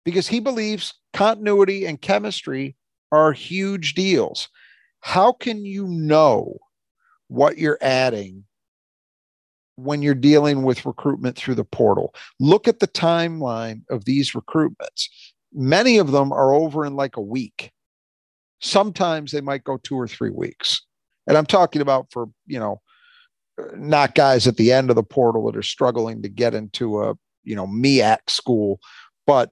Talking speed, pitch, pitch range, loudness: 150 wpm, 140 Hz, 125-185 Hz, -20 LUFS